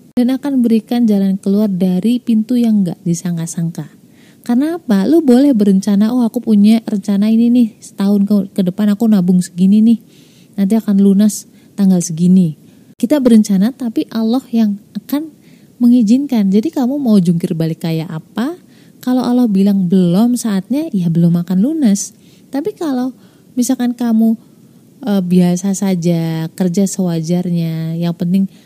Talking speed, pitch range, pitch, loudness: 140 wpm, 185-240 Hz, 210 Hz, -14 LUFS